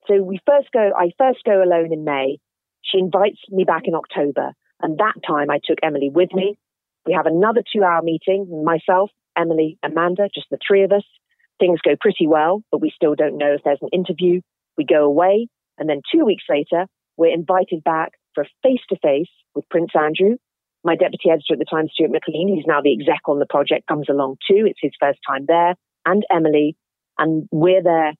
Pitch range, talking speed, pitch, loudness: 150-195 Hz, 200 wpm, 170 Hz, -18 LUFS